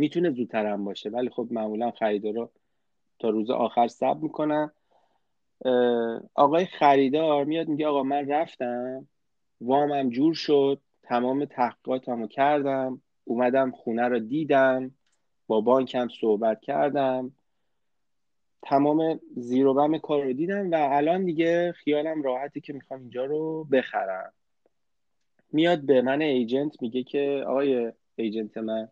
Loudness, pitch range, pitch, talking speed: -25 LUFS, 120-150 Hz, 135 Hz, 130 wpm